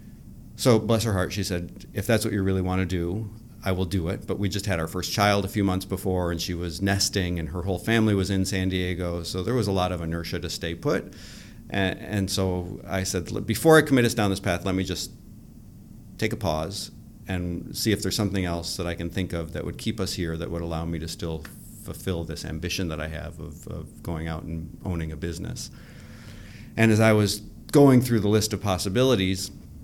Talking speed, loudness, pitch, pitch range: 230 wpm, -25 LUFS, 95 Hz, 85-105 Hz